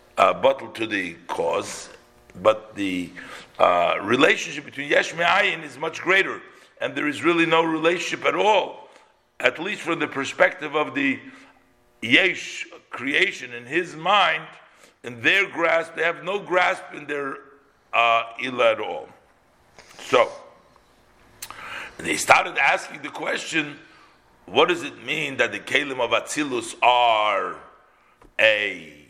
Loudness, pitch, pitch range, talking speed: -22 LUFS, 165 Hz, 130-205 Hz, 135 wpm